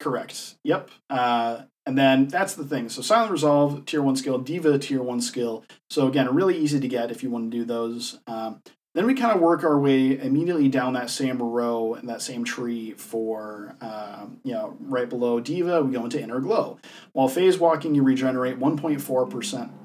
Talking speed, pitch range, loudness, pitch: 195 wpm, 120-150 Hz, -24 LUFS, 130 Hz